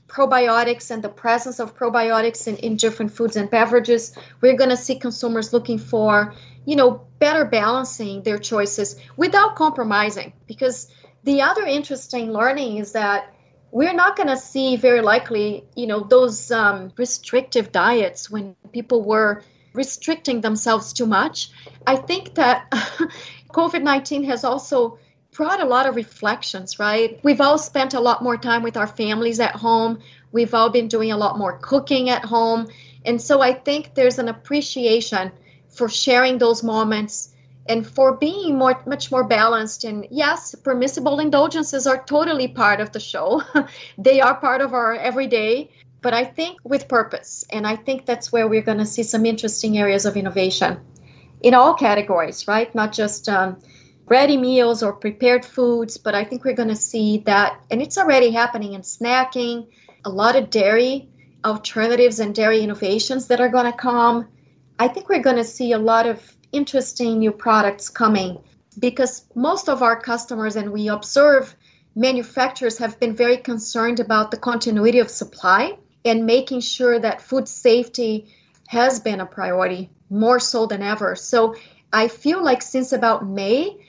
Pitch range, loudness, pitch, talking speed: 215-260 Hz, -19 LUFS, 235 Hz, 165 wpm